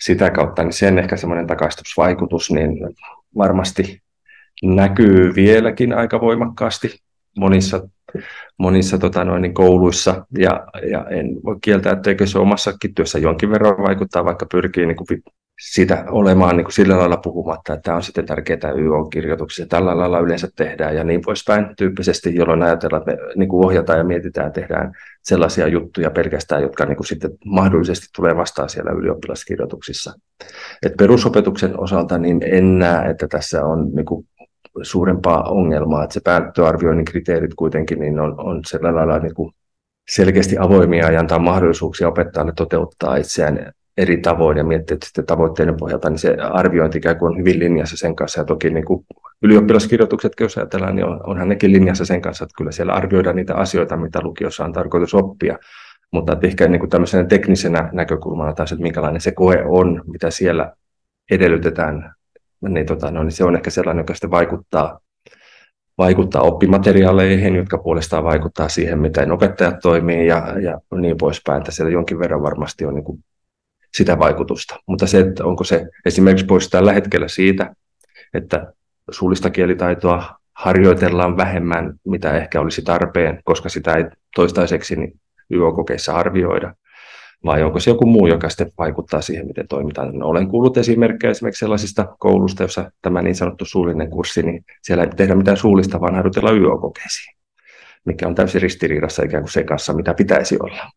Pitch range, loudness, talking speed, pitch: 80-95 Hz, -16 LUFS, 160 wpm, 90 Hz